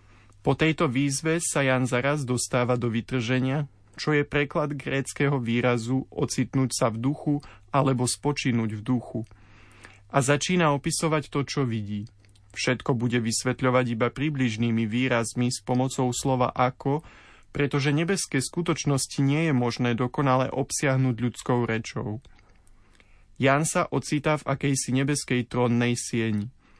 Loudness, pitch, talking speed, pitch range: -26 LUFS, 130 Hz, 125 wpm, 115-140 Hz